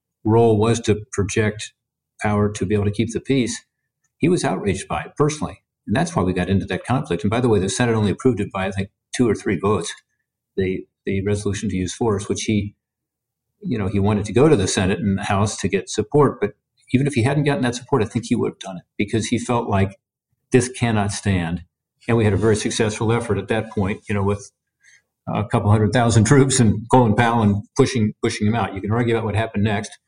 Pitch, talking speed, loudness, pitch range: 110 Hz, 240 wpm, -20 LUFS, 100-120 Hz